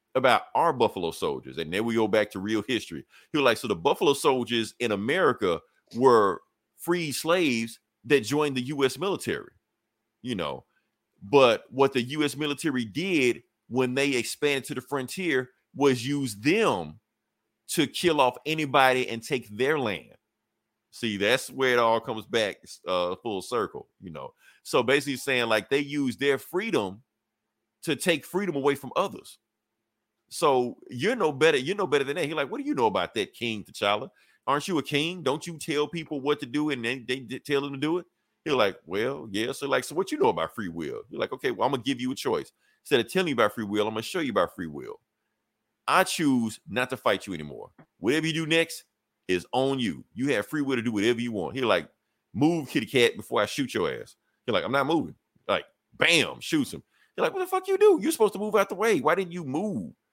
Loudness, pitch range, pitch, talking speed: -26 LUFS, 115-185 Hz, 140 Hz, 215 wpm